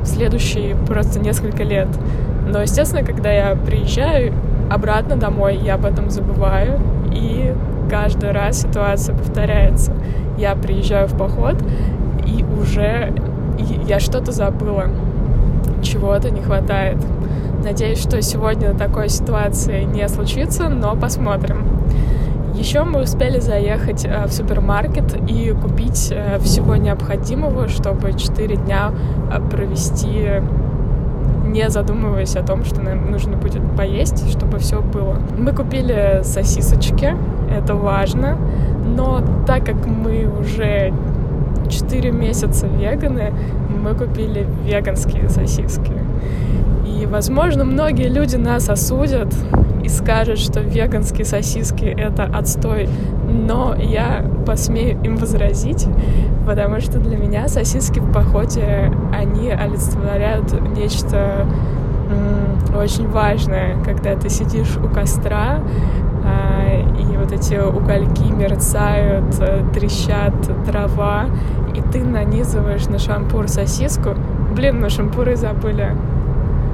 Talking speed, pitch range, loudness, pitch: 105 wpm, 65-80 Hz, -18 LUFS, 70 Hz